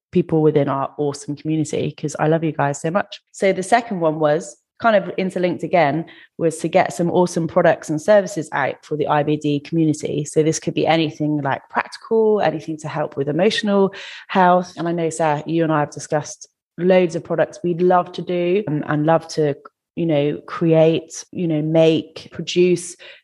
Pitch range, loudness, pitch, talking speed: 150-180 Hz, -19 LUFS, 160 Hz, 190 wpm